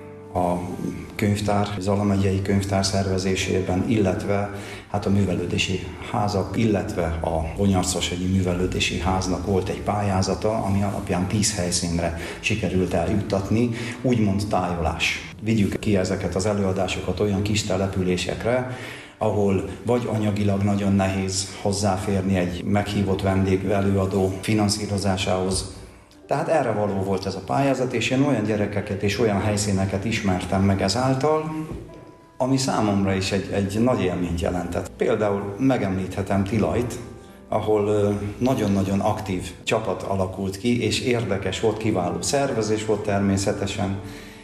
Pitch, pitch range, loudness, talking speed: 100 Hz, 95-105 Hz, -23 LUFS, 115 wpm